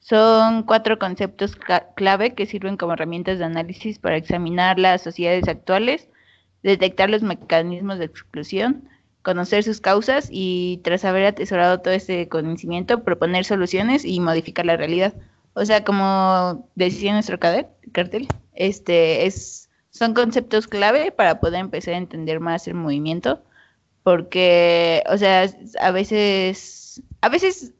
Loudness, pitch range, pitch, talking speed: -20 LUFS, 175-210 Hz, 185 Hz, 135 wpm